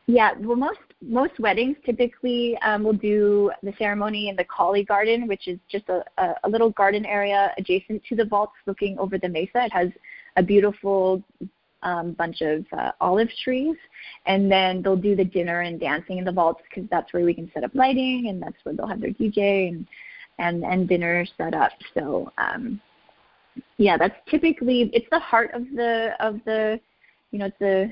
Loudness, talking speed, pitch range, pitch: -23 LUFS, 195 wpm, 185-235 Hz, 205 Hz